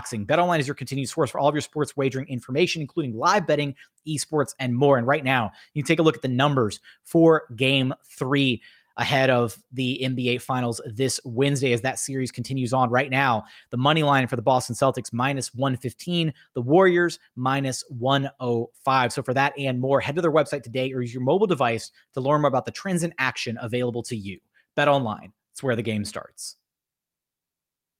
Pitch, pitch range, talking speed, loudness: 135 Hz, 125-145 Hz, 200 wpm, -24 LUFS